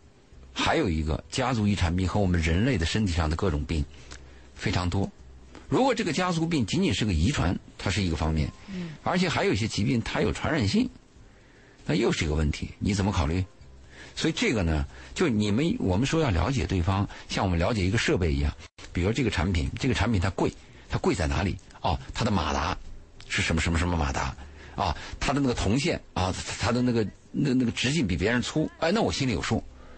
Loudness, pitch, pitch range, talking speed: -27 LUFS, 95 Hz, 80-110 Hz, 315 characters per minute